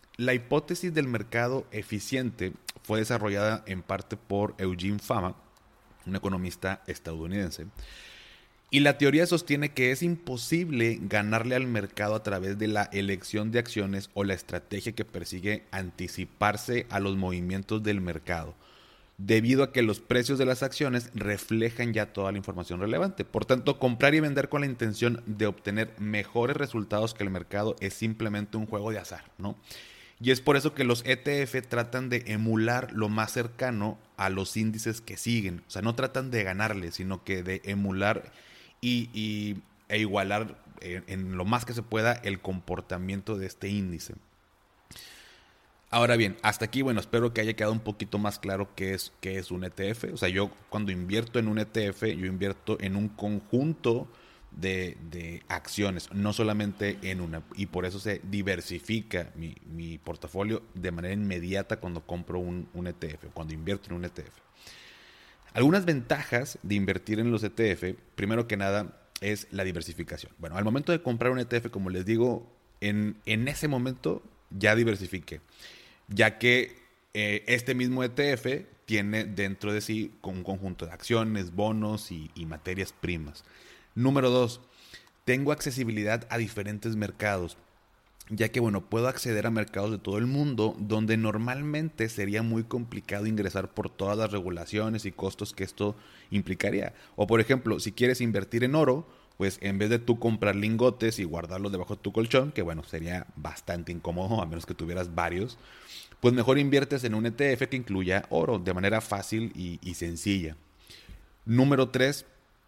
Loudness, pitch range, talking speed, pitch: -29 LUFS, 95-120 Hz, 165 wpm, 105 Hz